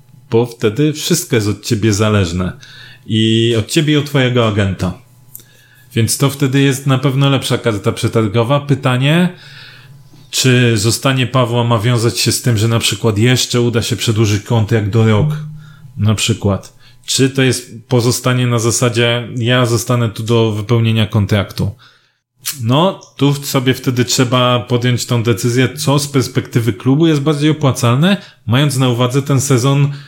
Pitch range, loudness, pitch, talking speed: 115-135 Hz, -14 LUFS, 125 Hz, 155 wpm